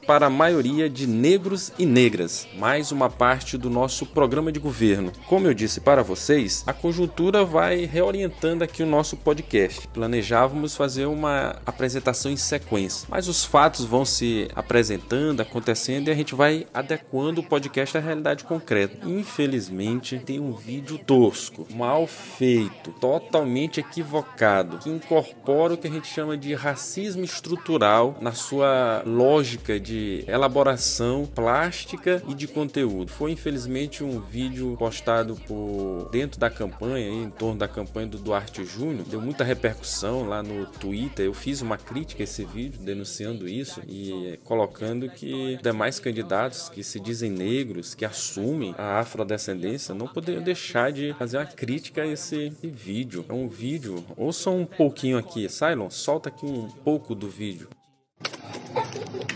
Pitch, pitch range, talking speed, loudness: 130 Hz, 110-150 Hz, 150 wpm, -25 LUFS